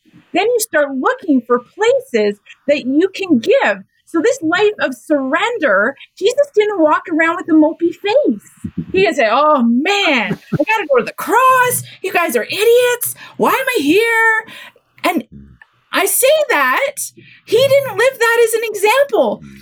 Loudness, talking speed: -14 LUFS, 160 wpm